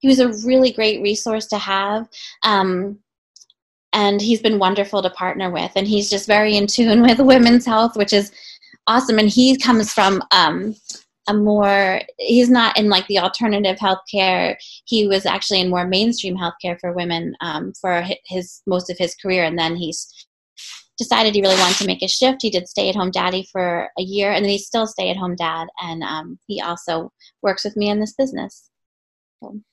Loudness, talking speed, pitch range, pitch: -17 LUFS, 195 wpm, 185-220 Hz, 200 Hz